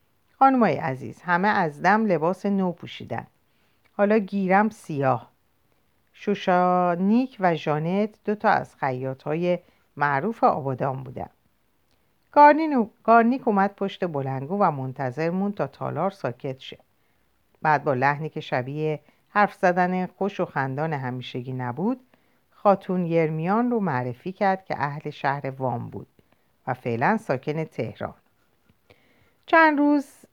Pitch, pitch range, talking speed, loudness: 180 Hz, 140-205 Hz, 120 wpm, -24 LUFS